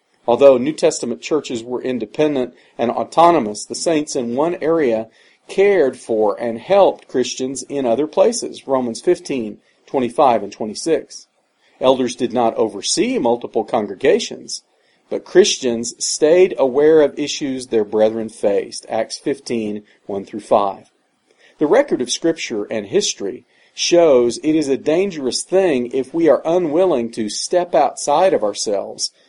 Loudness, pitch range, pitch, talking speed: -17 LUFS, 115-165 Hz, 135 Hz, 135 wpm